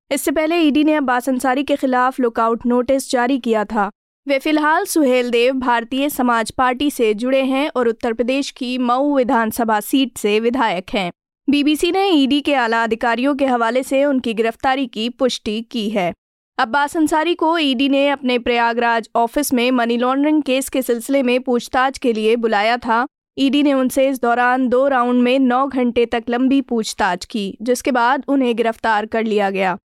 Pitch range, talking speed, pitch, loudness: 235-275 Hz, 180 wpm, 250 Hz, -17 LUFS